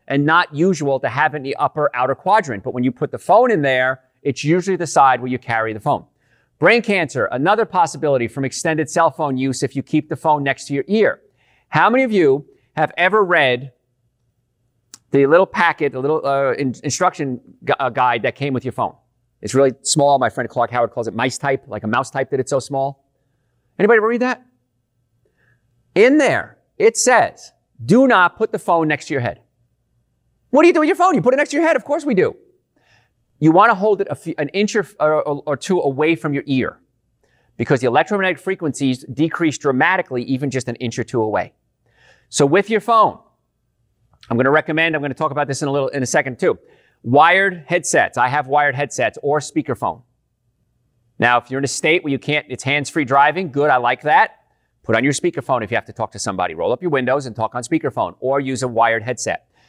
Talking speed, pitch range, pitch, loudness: 220 wpm, 125-165 Hz, 140 Hz, -17 LUFS